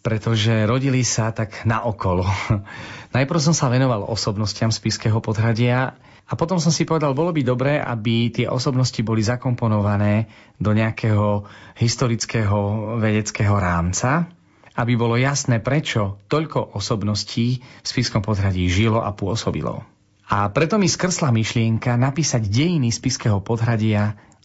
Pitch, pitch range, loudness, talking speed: 115 Hz, 105-130 Hz, -20 LUFS, 135 wpm